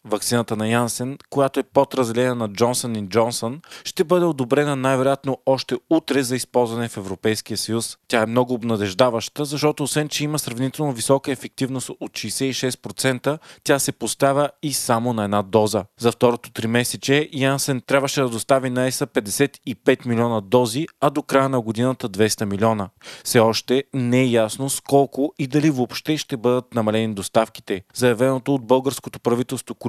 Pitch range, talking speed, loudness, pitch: 115-140 Hz, 160 wpm, -21 LUFS, 130 Hz